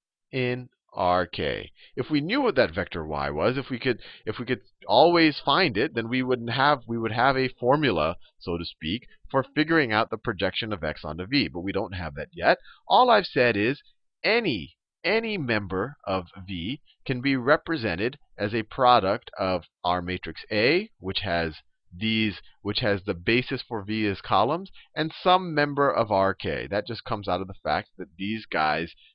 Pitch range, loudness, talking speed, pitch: 95-130 Hz, -25 LUFS, 185 wpm, 110 Hz